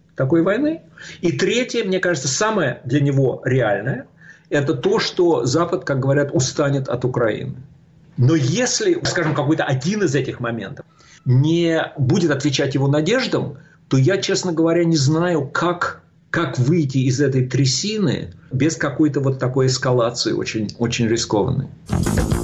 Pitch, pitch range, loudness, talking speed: 150 Hz, 135-170 Hz, -19 LUFS, 140 wpm